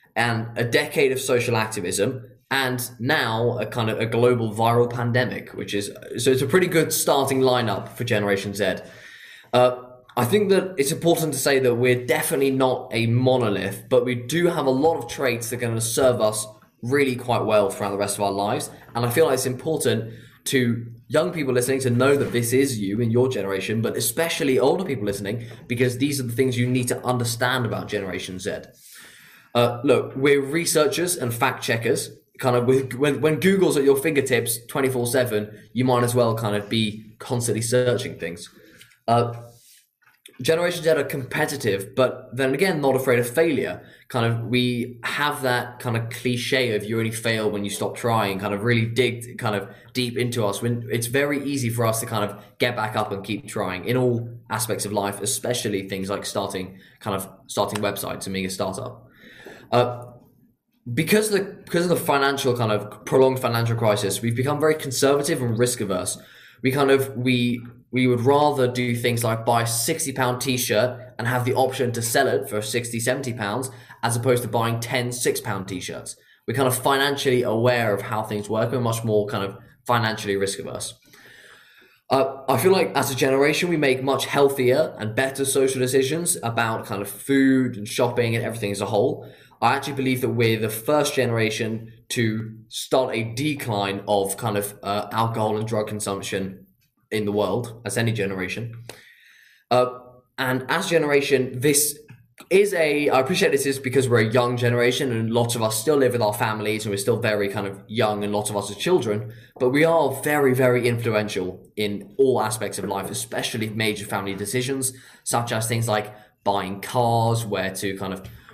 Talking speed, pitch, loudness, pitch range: 195 wpm, 120 Hz, -22 LUFS, 110-130 Hz